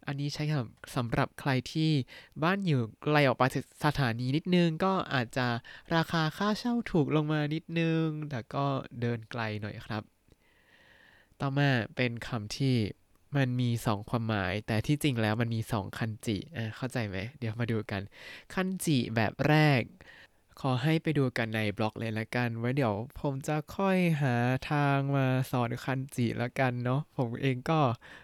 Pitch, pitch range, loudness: 130 Hz, 115-150 Hz, -31 LUFS